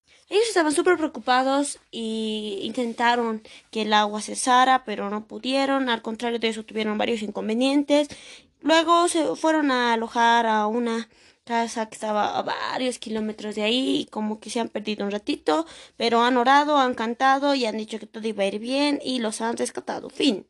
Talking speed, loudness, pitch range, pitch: 180 wpm, -23 LUFS, 220-270 Hz, 235 Hz